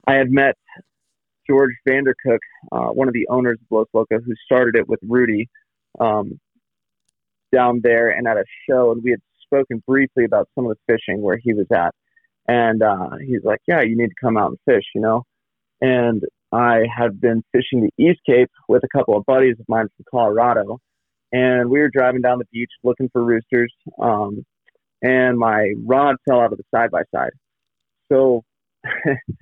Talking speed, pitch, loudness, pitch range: 185 wpm, 120 Hz, -18 LUFS, 115-130 Hz